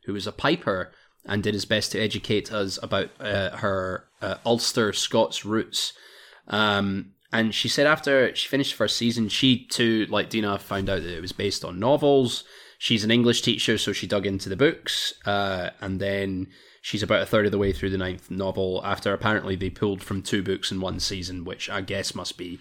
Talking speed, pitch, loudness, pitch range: 205 wpm, 100 Hz, -25 LUFS, 95-115 Hz